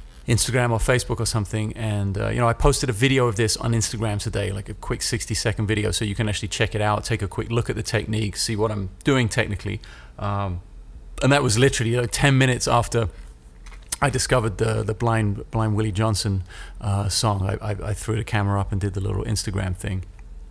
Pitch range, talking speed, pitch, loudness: 100-115 Hz, 220 wpm, 110 Hz, -23 LUFS